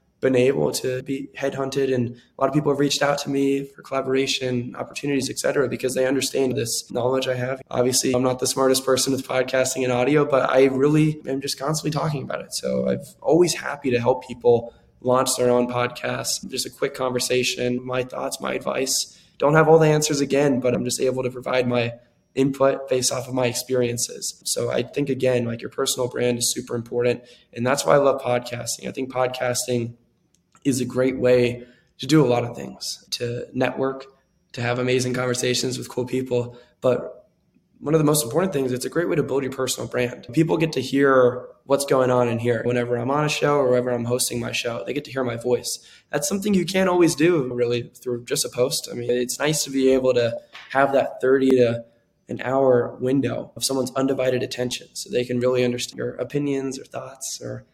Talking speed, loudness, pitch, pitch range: 210 wpm, -22 LUFS, 130 Hz, 125-135 Hz